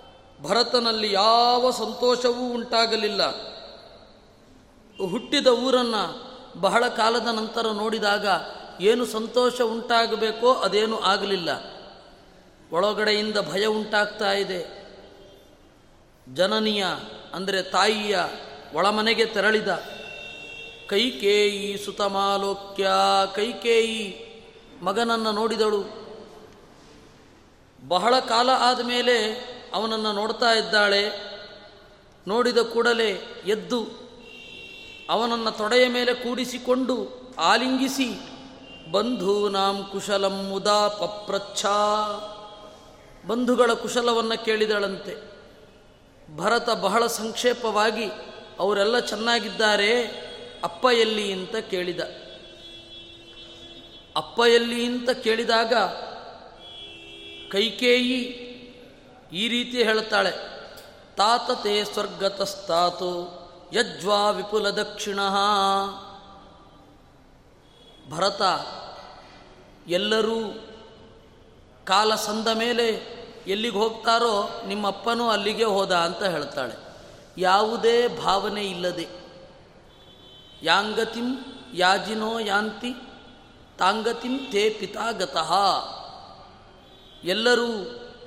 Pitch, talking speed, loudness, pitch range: 215 Hz, 65 wpm, -23 LUFS, 200-235 Hz